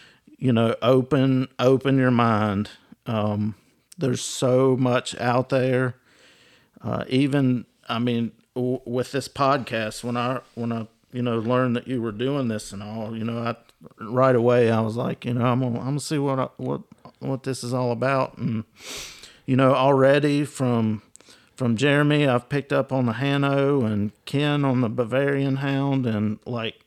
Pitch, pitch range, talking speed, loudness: 125 Hz, 115-135 Hz, 175 wpm, -23 LUFS